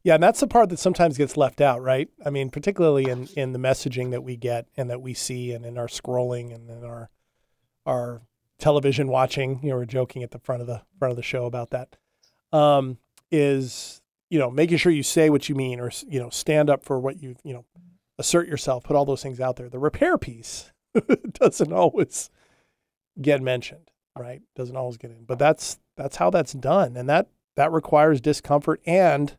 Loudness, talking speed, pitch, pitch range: -23 LUFS, 210 wpm, 135 Hz, 125-150 Hz